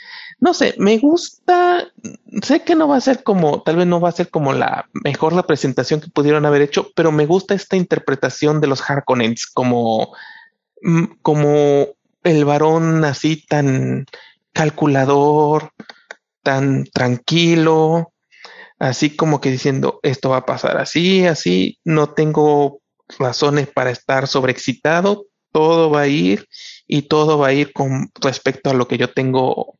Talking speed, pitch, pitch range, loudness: 150 wpm, 150 Hz, 140-175 Hz, -16 LUFS